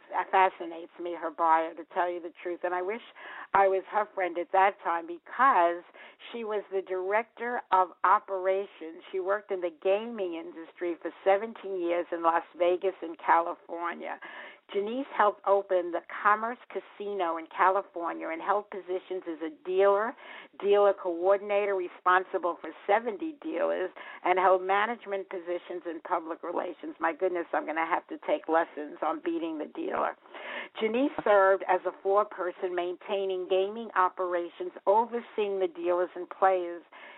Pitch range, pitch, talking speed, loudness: 175-200 Hz, 185 Hz, 155 wpm, -29 LUFS